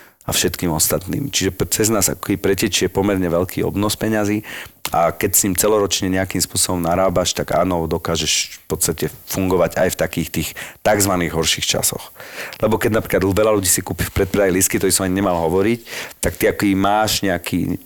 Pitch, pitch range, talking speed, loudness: 95 Hz, 85-105 Hz, 180 wpm, -18 LUFS